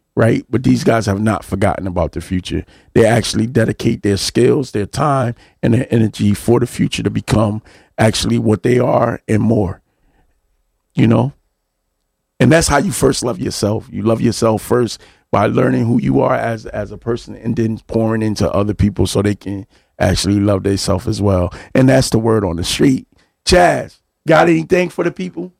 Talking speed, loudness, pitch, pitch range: 190 wpm, -15 LUFS, 110 Hz, 100-120 Hz